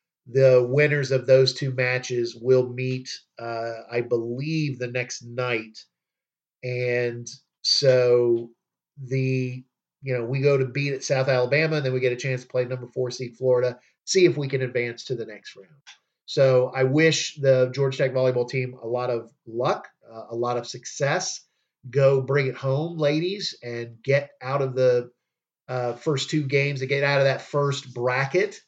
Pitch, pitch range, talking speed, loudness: 130 Hz, 125-140 Hz, 180 wpm, -24 LUFS